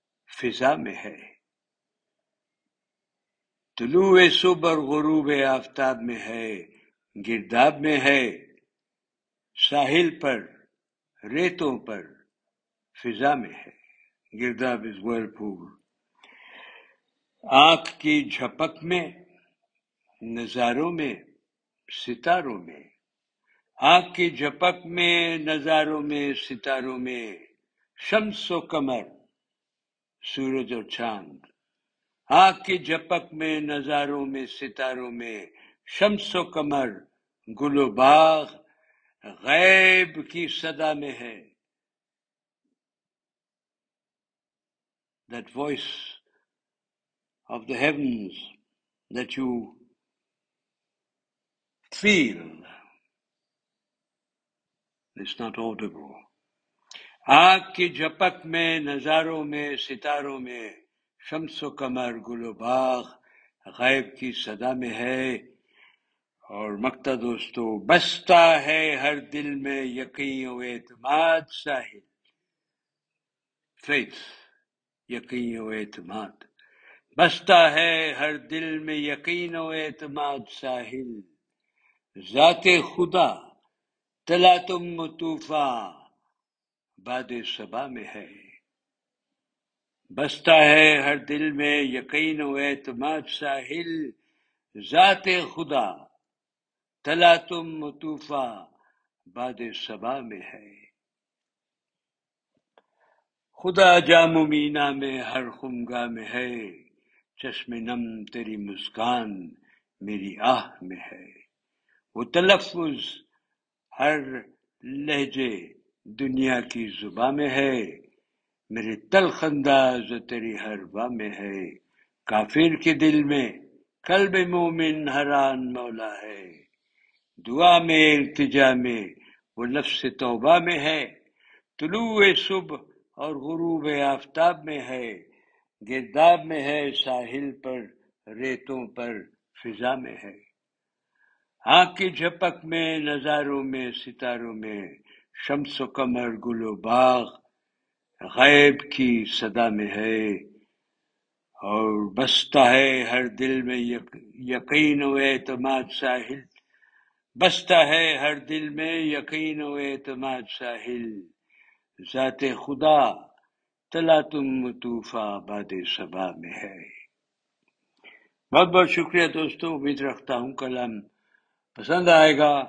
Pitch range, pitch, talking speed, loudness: 120-160 Hz, 140 Hz, 90 wpm, -23 LUFS